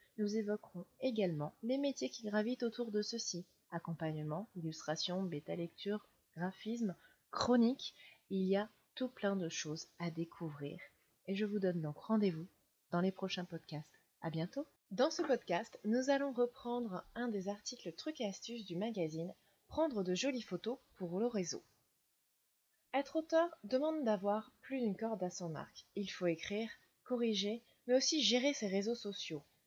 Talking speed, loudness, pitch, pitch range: 160 wpm, -39 LUFS, 205 Hz, 175-240 Hz